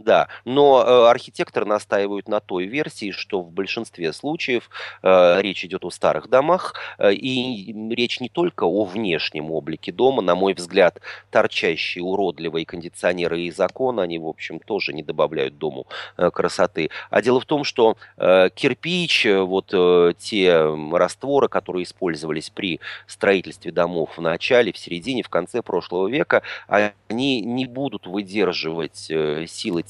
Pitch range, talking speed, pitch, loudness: 90-125 Hz, 145 wpm, 100 Hz, -21 LUFS